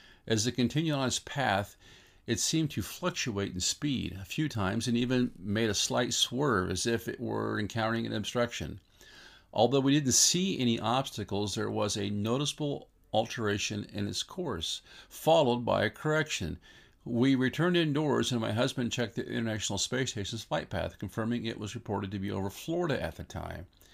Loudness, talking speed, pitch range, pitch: -31 LUFS, 175 wpm, 100-125 Hz, 115 Hz